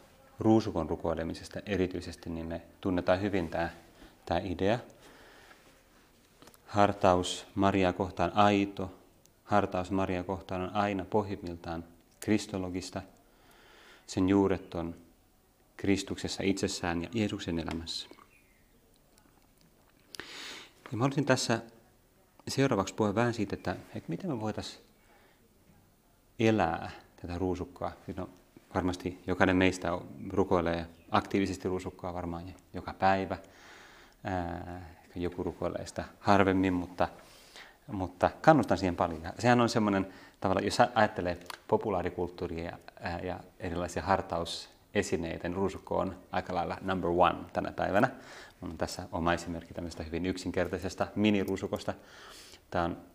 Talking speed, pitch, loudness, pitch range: 105 wpm, 95 Hz, -32 LUFS, 85-100 Hz